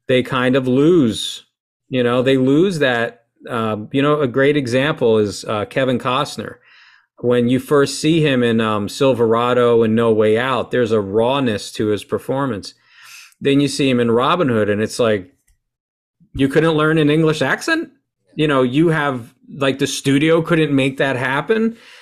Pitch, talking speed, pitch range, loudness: 135 Hz, 175 wpm, 120-150 Hz, -17 LUFS